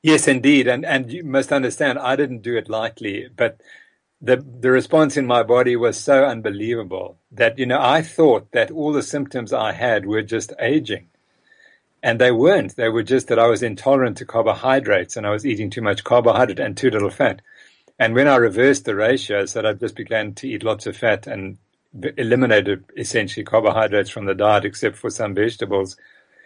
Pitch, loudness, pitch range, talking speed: 125 Hz, -19 LUFS, 110-135 Hz, 195 wpm